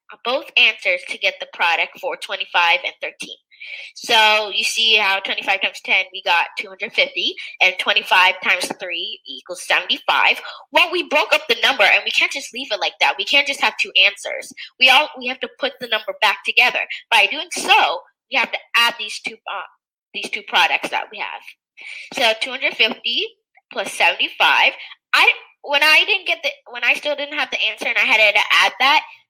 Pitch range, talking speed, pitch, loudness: 220-300 Hz, 215 wpm, 255 Hz, -16 LUFS